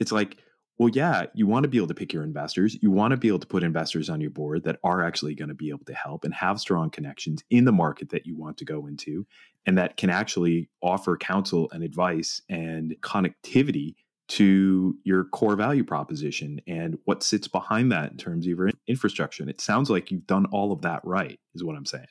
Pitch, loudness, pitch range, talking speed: 90 Hz, -26 LUFS, 80-105 Hz, 230 wpm